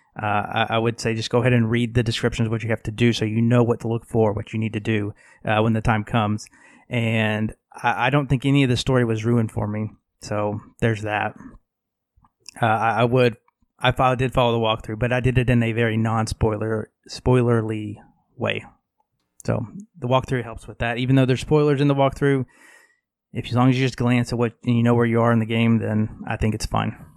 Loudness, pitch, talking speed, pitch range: -21 LUFS, 115 Hz, 240 wpm, 110-125 Hz